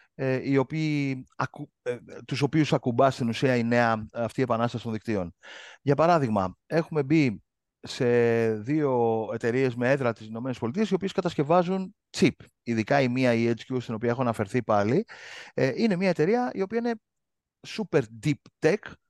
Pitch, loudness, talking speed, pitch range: 130 Hz, -26 LUFS, 145 wpm, 115-155 Hz